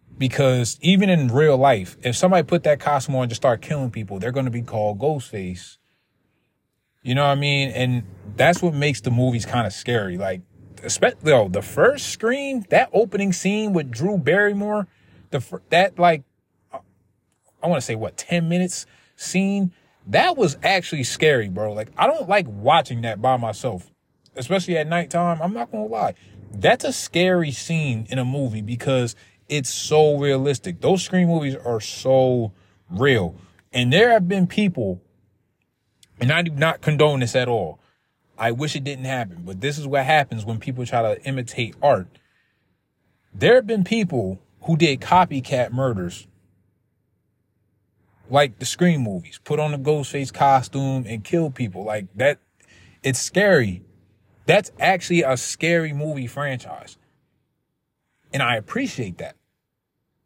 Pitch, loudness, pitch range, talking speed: 130 Hz, -21 LUFS, 110-165 Hz, 160 wpm